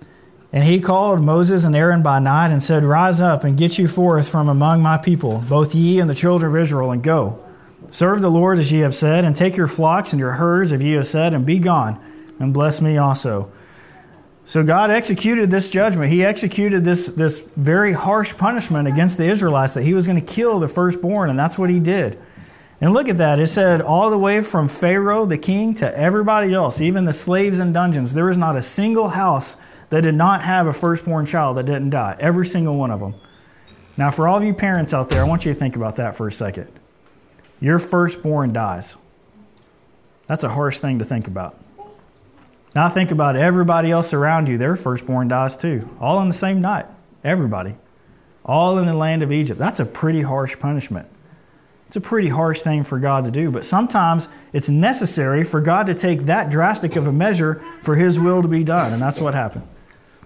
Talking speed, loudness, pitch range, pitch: 210 wpm, -17 LUFS, 145-180 Hz, 160 Hz